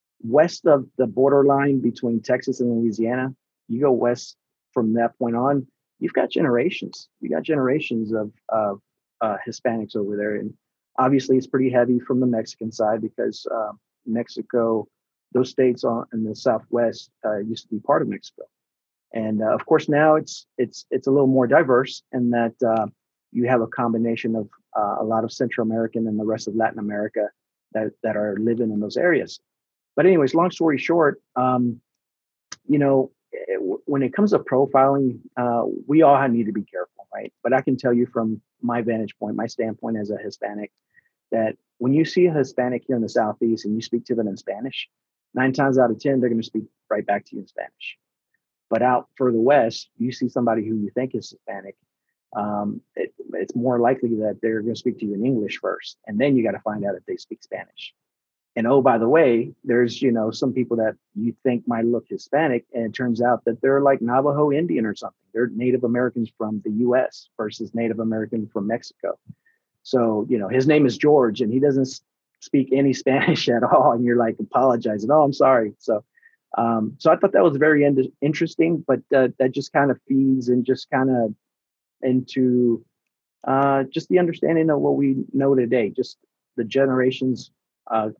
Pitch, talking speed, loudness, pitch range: 125 Hz, 200 wpm, -21 LUFS, 115-135 Hz